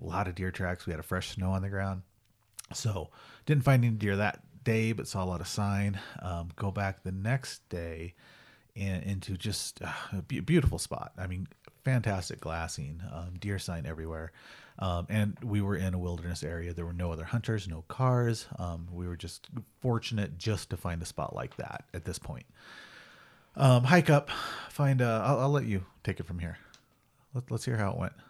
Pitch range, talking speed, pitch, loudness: 90-115 Hz, 200 wpm, 100 Hz, -32 LUFS